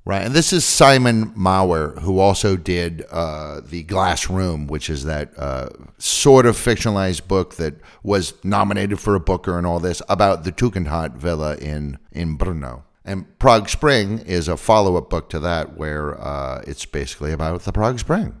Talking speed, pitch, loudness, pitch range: 180 wpm, 90 Hz, -19 LUFS, 80-100 Hz